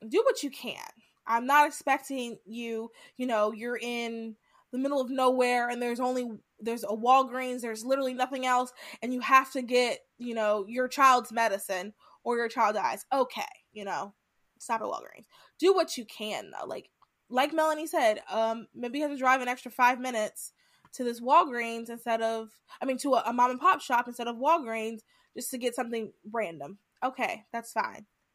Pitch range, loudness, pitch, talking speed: 230-265 Hz, -29 LUFS, 245 Hz, 190 wpm